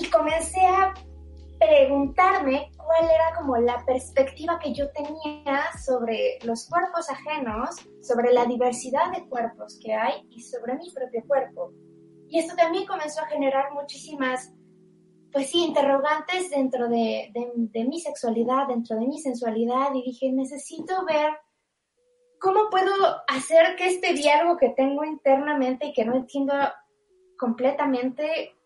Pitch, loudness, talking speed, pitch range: 280 Hz, -24 LUFS, 140 wpm, 250-325 Hz